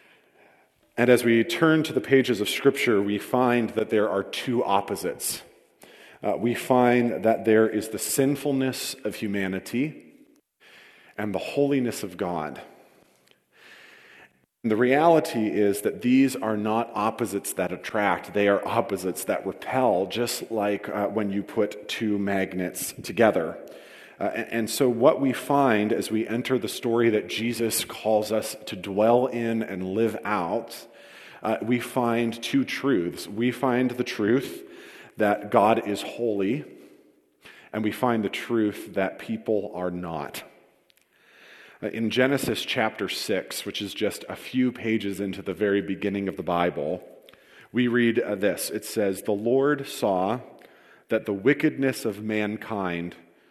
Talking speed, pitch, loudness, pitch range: 150 wpm, 115 Hz, -25 LUFS, 100-125 Hz